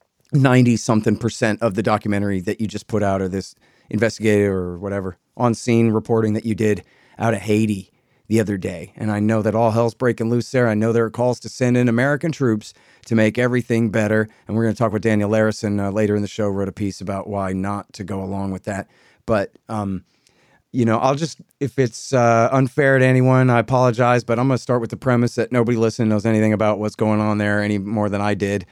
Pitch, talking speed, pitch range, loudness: 110 Hz, 235 wpm, 105-120 Hz, -19 LUFS